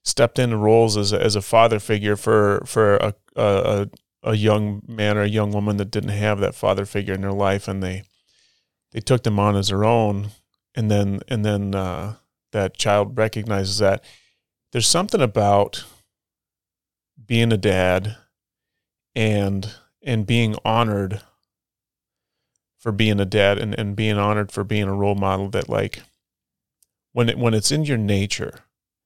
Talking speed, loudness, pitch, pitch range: 165 wpm, -20 LUFS, 105 Hz, 100-110 Hz